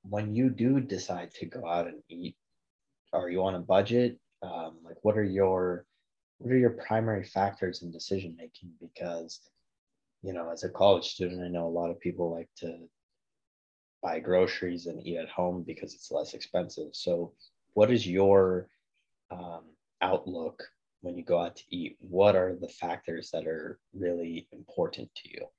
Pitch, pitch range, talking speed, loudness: 90 Hz, 85-105 Hz, 175 wpm, -30 LUFS